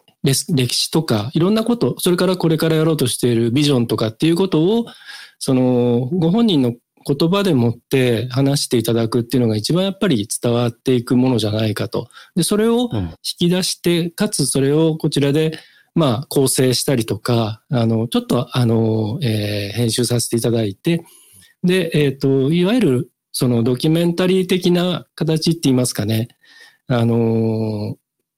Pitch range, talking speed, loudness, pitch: 120-170 Hz, 335 characters per minute, -17 LUFS, 135 Hz